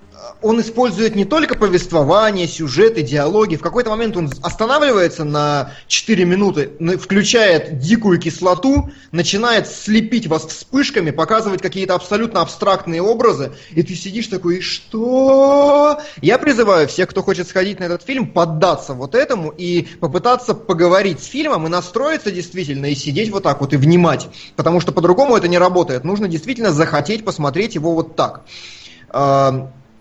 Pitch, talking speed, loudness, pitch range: 180 Hz, 145 wpm, -16 LUFS, 160-220 Hz